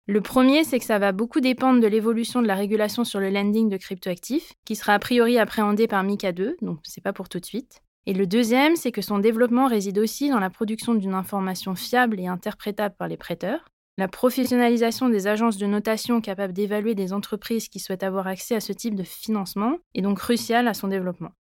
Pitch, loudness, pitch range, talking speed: 215 Hz, -23 LUFS, 195-235 Hz, 215 wpm